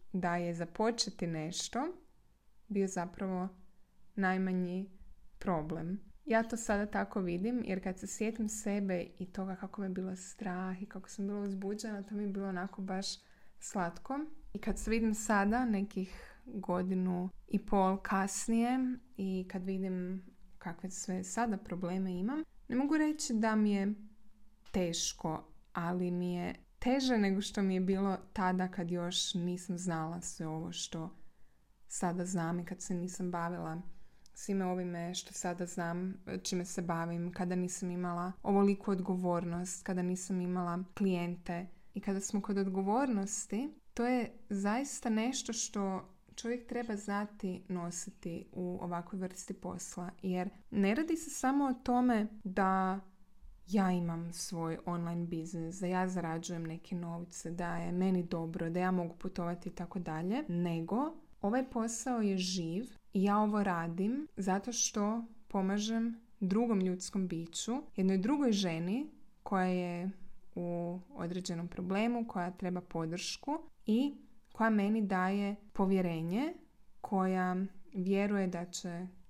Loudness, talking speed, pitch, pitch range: -36 LUFS, 140 wpm, 190 Hz, 180-210 Hz